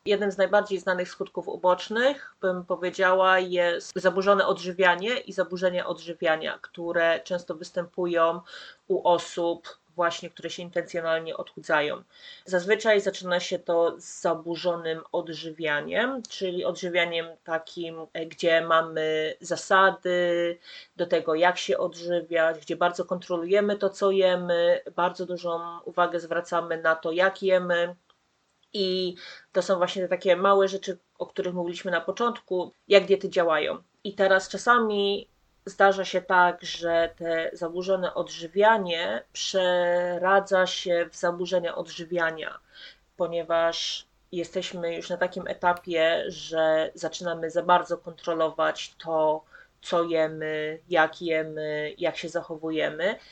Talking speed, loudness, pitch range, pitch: 120 wpm, -26 LUFS, 170-185 Hz, 175 Hz